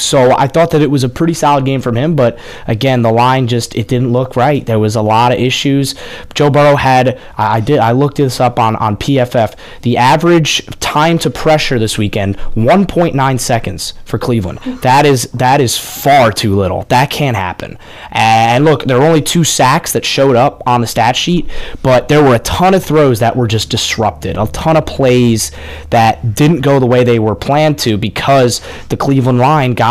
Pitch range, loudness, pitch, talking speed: 115-145 Hz, -11 LUFS, 125 Hz, 210 wpm